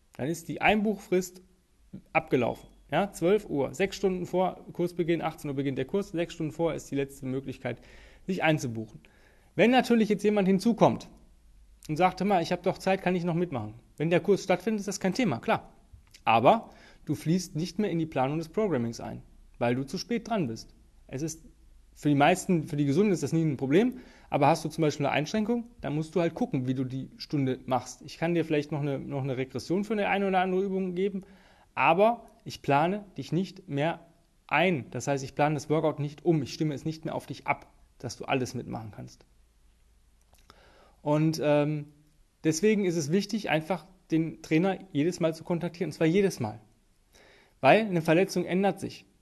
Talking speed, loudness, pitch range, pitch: 200 wpm, -28 LUFS, 140-185 Hz, 160 Hz